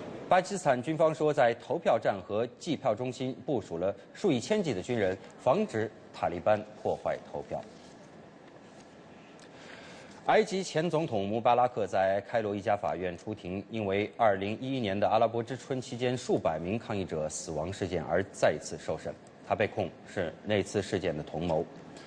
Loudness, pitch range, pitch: -31 LUFS, 100-130 Hz, 115 Hz